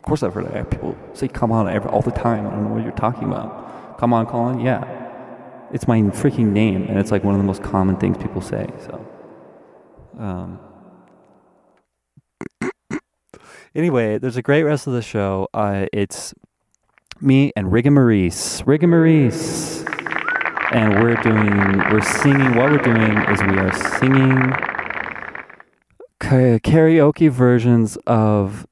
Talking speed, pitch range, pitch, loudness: 145 wpm, 100-130 Hz, 115 Hz, -18 LUFS